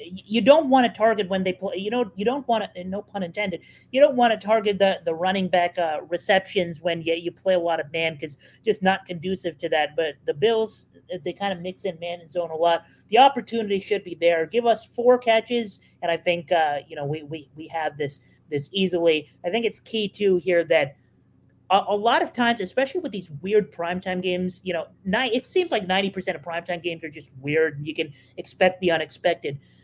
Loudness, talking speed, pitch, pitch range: -23 LUFS, 235 wpm, 185 Hz, 165-215 Hz